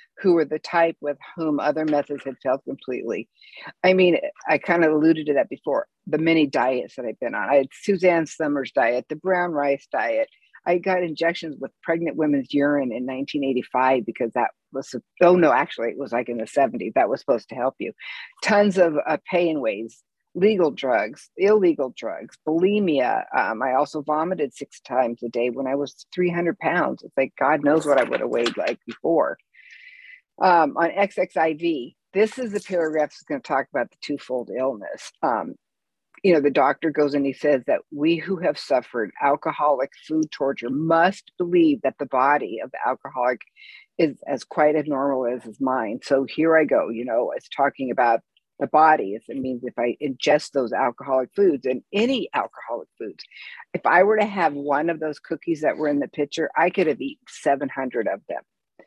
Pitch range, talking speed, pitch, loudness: 140-180 Hz, 195 wpm, 155 Hz, -22 LUFS